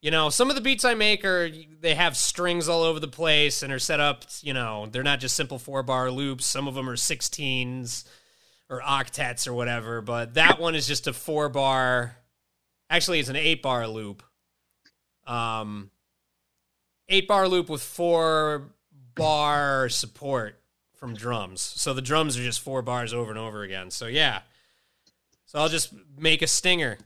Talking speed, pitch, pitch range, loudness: 180 wpm, 135 Hz, 120-155 Hz, -24 LUFS